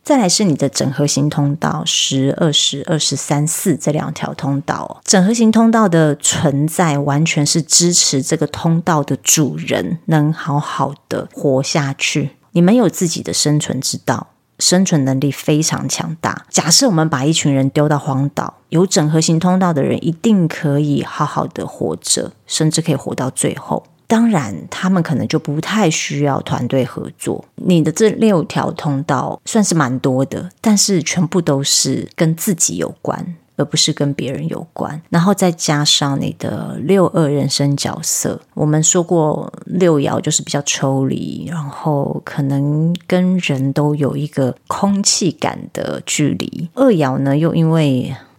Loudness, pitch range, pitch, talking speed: -15 LUFS, 145-175 Hz, 155 Hz, 245 characters per minute